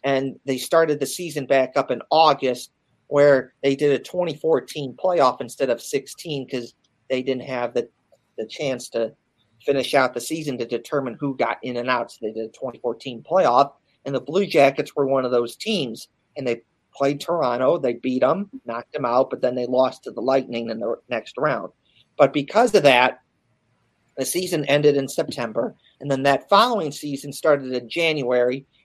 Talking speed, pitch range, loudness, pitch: 185 wpm, 125-150 Hz, -22 LUFS, 135 Hz